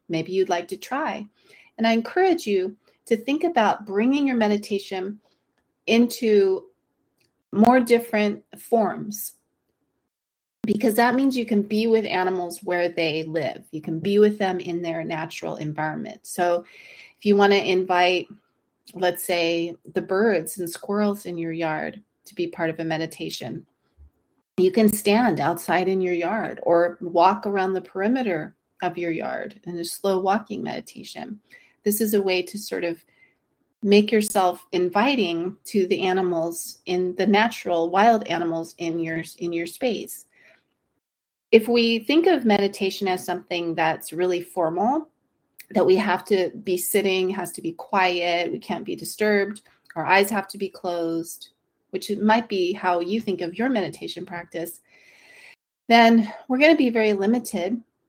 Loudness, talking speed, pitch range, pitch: -23 LUFS, 155 wpm, 175-220 Hz, 190 Hz